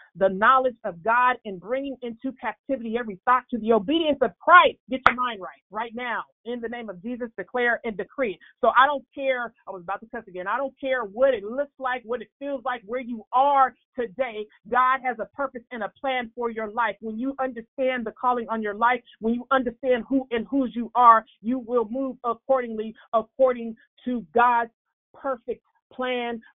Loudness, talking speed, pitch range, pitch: -24 LUFS, 200 wpm, 225-260 Hz, 245 Hz